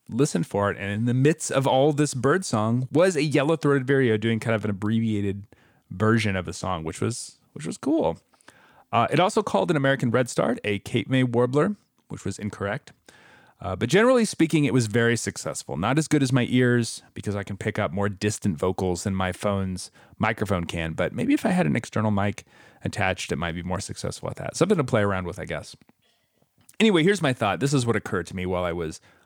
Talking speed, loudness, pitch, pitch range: 225 wpm, -24 LUFS, 115 Hz, 100-135 Hz